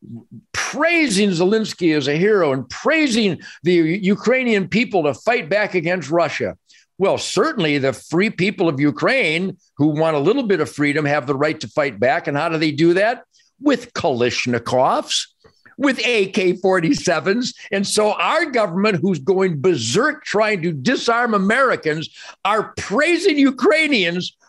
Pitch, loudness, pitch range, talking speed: 190 Hz, -18 LUFS, 155-225 Hz, 145 wpm